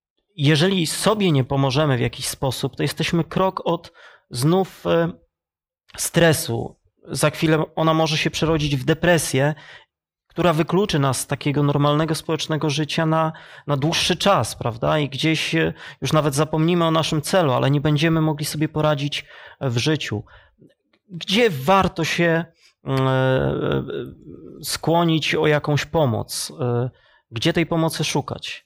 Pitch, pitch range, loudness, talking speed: 155 Hz, 140-165 Hz, -20 LUFS, 130 wpm